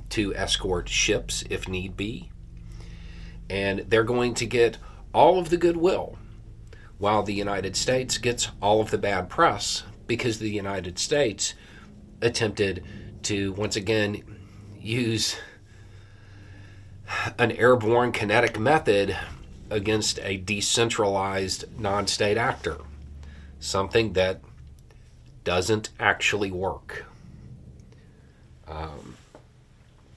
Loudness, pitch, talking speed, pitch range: -25 LUFS, 105 Hz, 100 wpm, 95-115 Hz